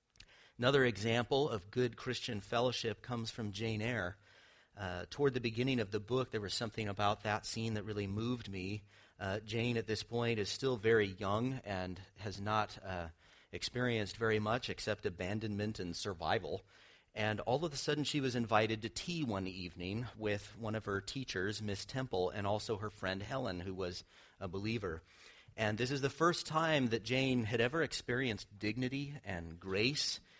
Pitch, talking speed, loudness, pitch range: 110 Hz, 175 wpm, -37 LUFS, 100-125 Hz